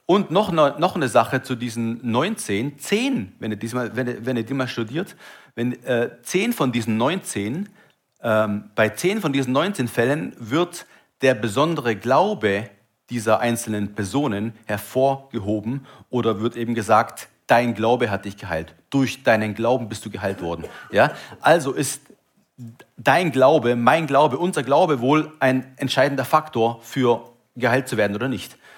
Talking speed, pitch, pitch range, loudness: 155 wpm, 125 Hz, 115-140 Hz, -21 LUFS